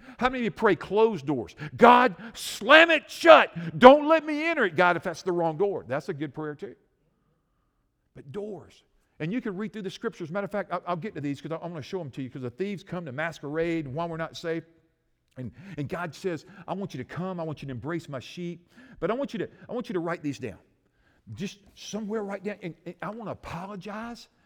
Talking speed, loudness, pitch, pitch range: 250 wpm, -25 LUFS, 175 Hz, 155-210 Hz